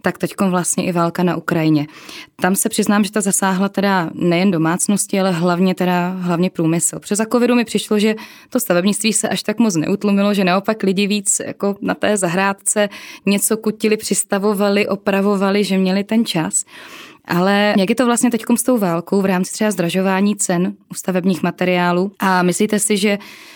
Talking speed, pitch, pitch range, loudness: 180 wpm, 195 Hz, 180-215 Hz, -17 LUFS